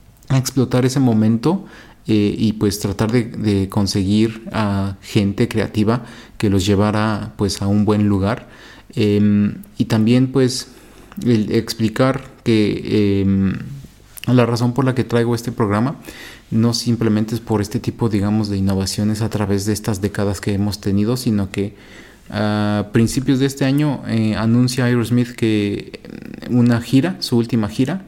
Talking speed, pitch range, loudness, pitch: 150 wpm, 105-120 Hz, -18 LUFS, 110 Hz